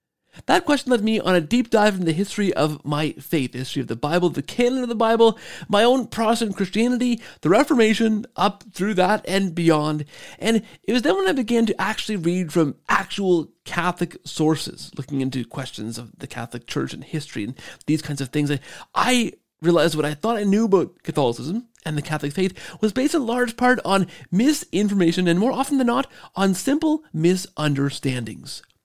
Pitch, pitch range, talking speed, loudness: 190 Hz, 155-230 Hz, 190 wpm, -21 LUFS